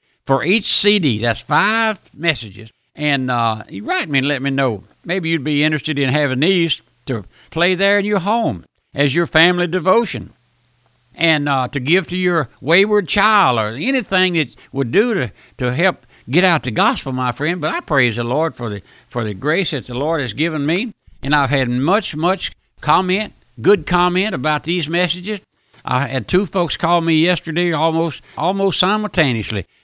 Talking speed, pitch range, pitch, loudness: 185 wpm, 130-185 Hz, 160 Hz, -17 LUFS